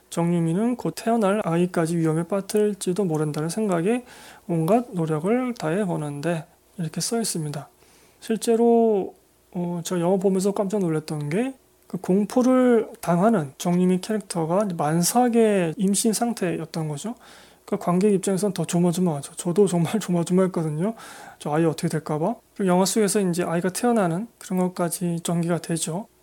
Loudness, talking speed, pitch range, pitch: -23 LUFS, 335 characters per minute, 170-215 Hz, 185 Hz